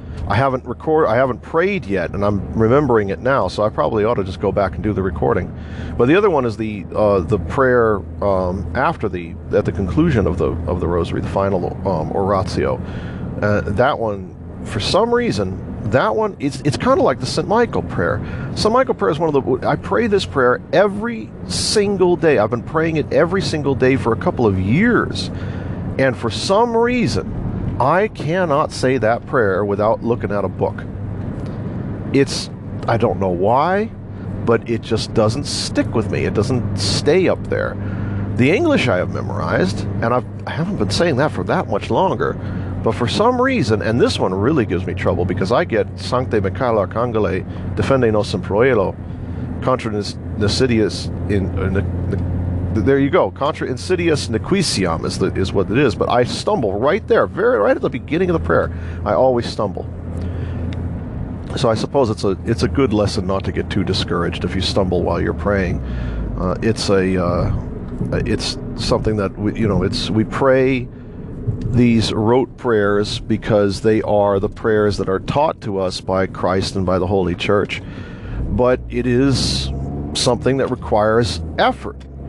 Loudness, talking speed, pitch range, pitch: -18 LUFS, 185 wpm, 95-120 Hz, 105 Hz